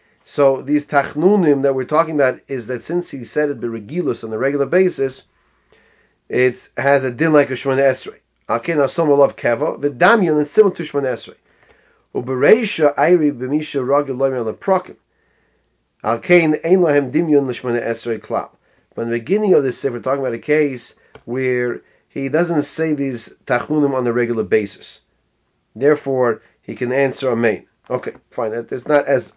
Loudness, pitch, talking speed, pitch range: -18 LUFS, 140 Hz, 160 wpm, 130-150 Hz